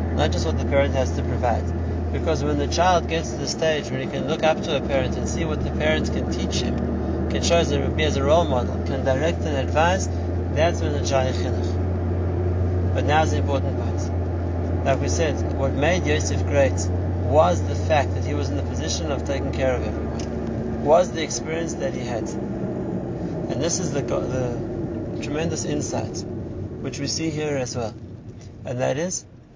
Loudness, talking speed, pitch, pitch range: -23 LUFS, 195 wpm, 85 Hz, 80-90 Hz